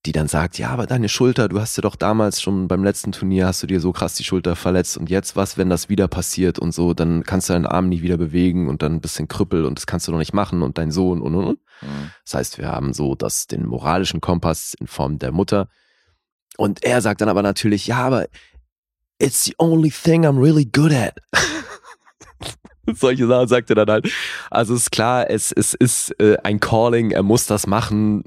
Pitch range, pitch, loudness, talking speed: 85-110 Hz, 95 Hz, -19 LUFS, 230 wpm